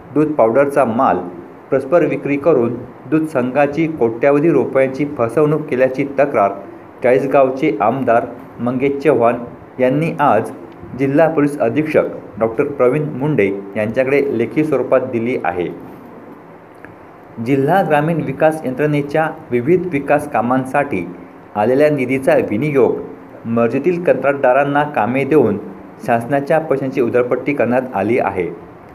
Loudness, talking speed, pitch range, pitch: -16 LUFS, 105 wpm, 120-150 Hz, 140 Hz